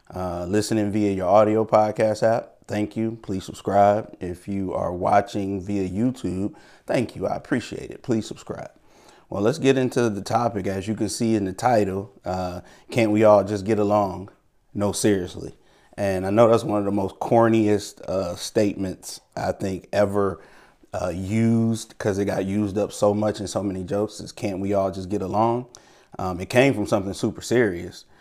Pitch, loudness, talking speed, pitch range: 105 Hz, -23 LUFS, 185 wpm, 95-110 Hz